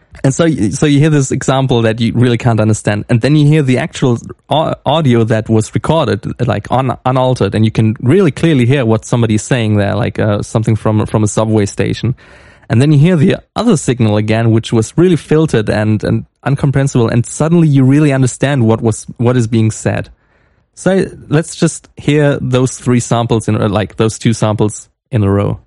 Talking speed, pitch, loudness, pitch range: 195 wpm, 120 Hz, -12 LUFS, 110-140 Hz